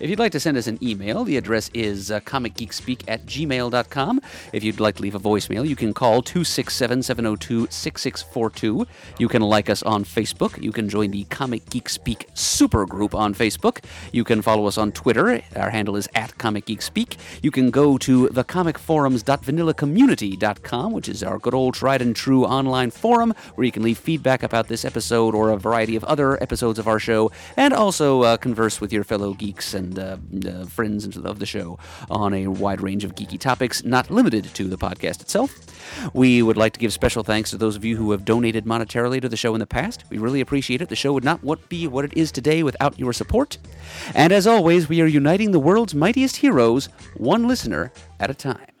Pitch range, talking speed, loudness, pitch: 105-135 Hz, 205 wpm, -21 LUFS, 115 Hz